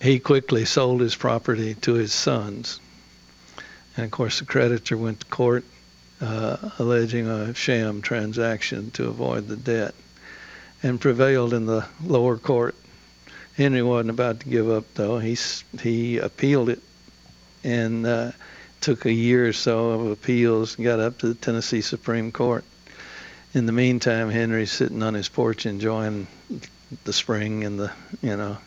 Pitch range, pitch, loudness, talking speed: 110-120 Hz, 115 Hz, -23 LUFS, 155 wpm